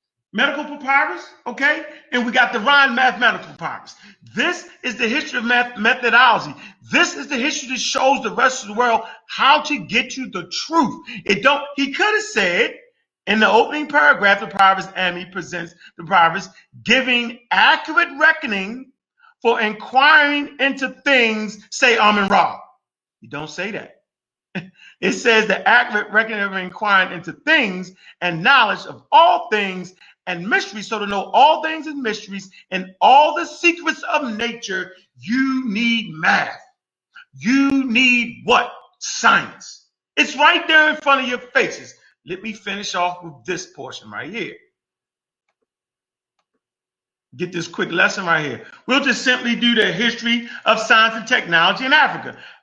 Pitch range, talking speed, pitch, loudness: 200-290 Hz, 155 wpm, 245 Hz, -17 LUFS